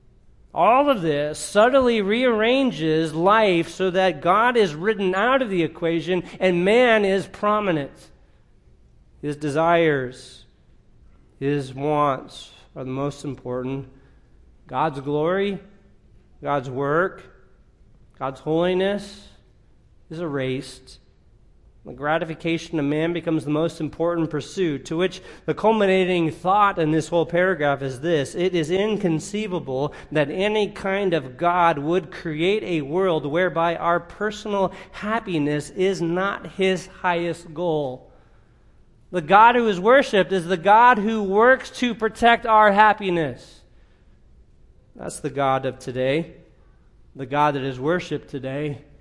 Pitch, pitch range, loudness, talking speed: 170 Hz, 150-195 Hz, -21 LUFS, 125 wpm